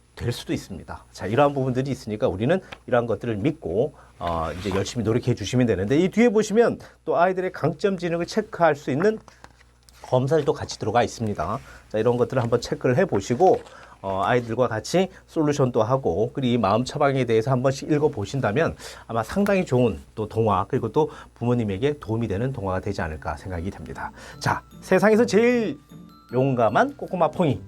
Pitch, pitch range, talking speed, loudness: 130 Hz, 105-165 Hz, 390 characters per minute, -23 LUFS